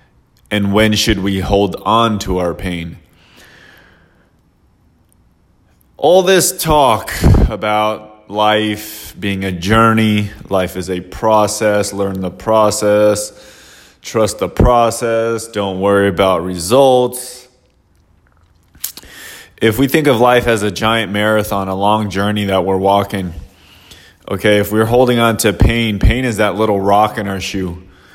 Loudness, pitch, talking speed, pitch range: -14 LUFS, 105 Hz, 130 wpm, 95-110 Hz